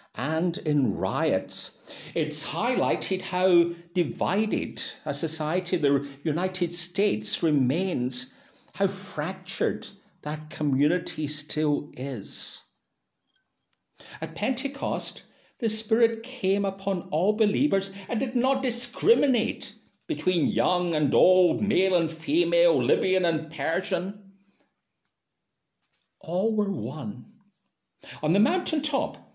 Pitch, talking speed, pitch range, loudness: 185 Hz, 100 wpm, 155-210 Hz, -26 LUFS